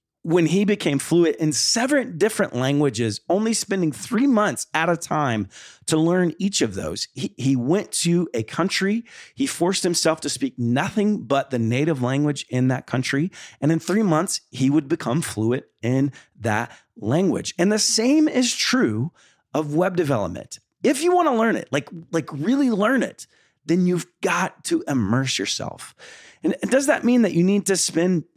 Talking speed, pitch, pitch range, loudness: 180 wpm, 170 Hz, 140-205 Hz, -21 LUFS